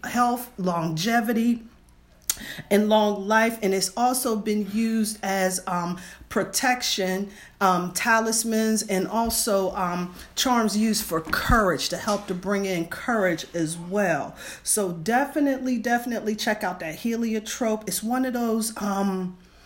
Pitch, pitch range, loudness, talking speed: 210 Hz, 185-230 Hz, -24 LUFS, 130 wpm